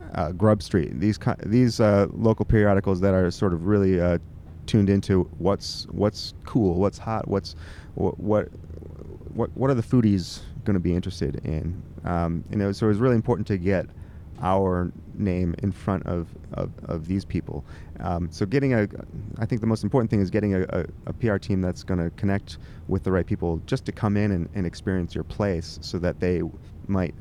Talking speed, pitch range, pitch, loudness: 195 wpm, 85-105 Hz, 95 Hz, -25 LUFS